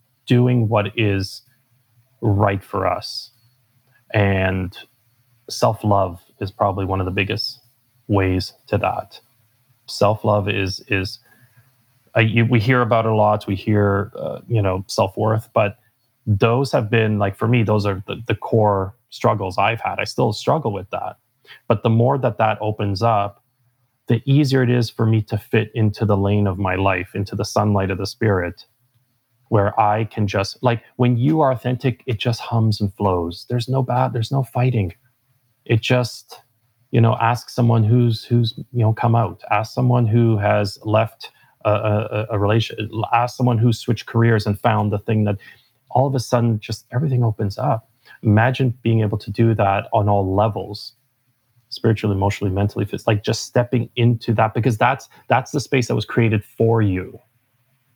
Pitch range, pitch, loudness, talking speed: 105-125 Hz, 115 Hz, -19 LUFS, 175 wpm